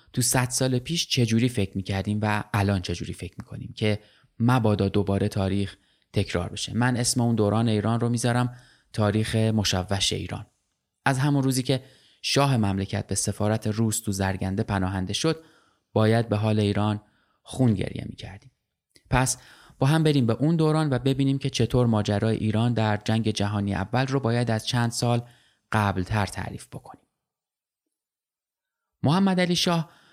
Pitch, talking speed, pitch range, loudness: 110 Hz, 155 wpm, 100-125 Hz, -25 LUFS